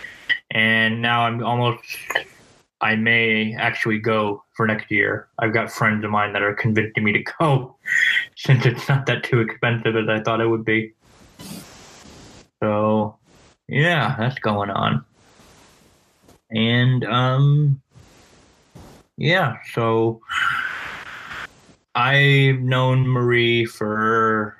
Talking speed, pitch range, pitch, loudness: 115 wpm, 110-130 Hz, 115 Hz, -20 LUFS